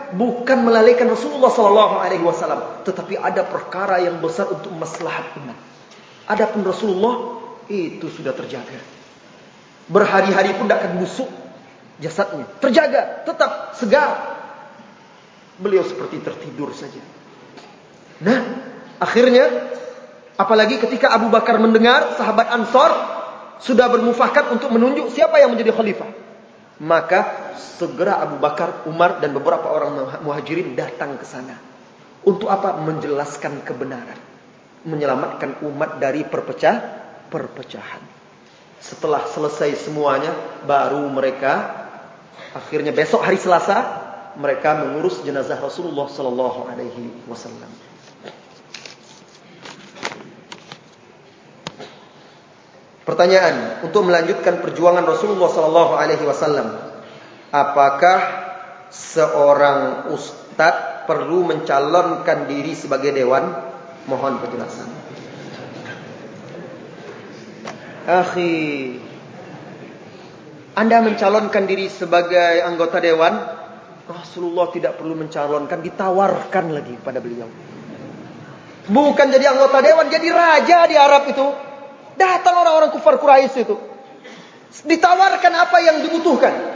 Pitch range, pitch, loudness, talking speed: 165-255 Hz, 195 Hz, -17 LUFS, 95 wpm